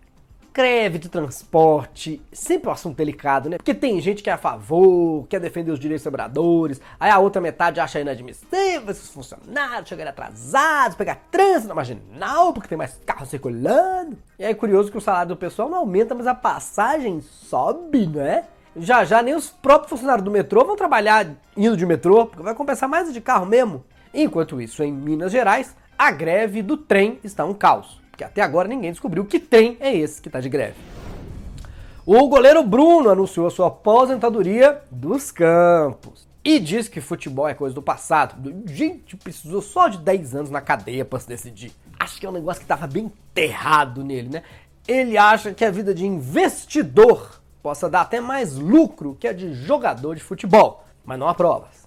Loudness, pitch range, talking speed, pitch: -19 LUFS, 150-255 Hz, 185 wpm, 190 Hz